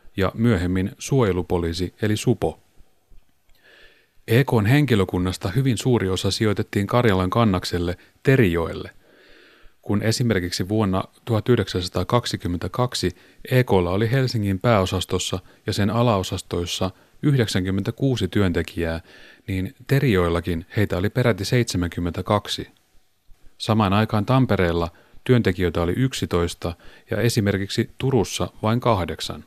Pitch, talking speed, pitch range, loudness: 100 Hz, 90 wpm, 90-120 Hz, -22 LUFS